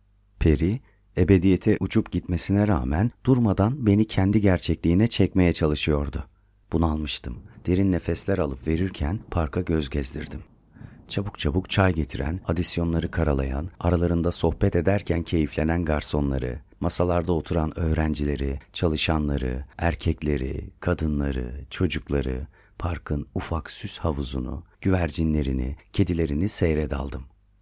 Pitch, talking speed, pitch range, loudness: 85 Hz, 95 wpm, 75-95 Hz, -25 LUFS